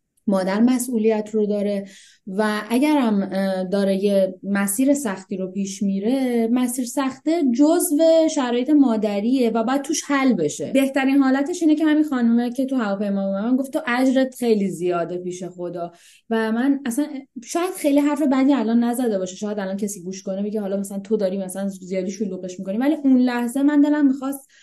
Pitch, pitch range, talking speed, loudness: 235 Hz, 195-270 Hz, 175 wpm, -21 LUFS